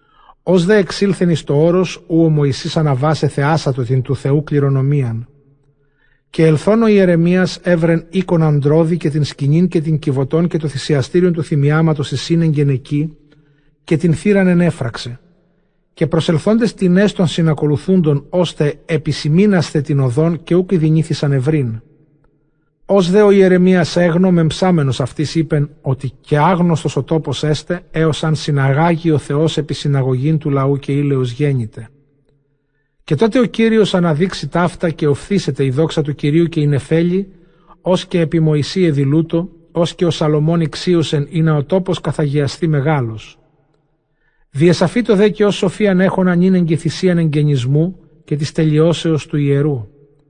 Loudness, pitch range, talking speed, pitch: -15 LUFS, 145-175 Hz, 150 wpm, 155 Hz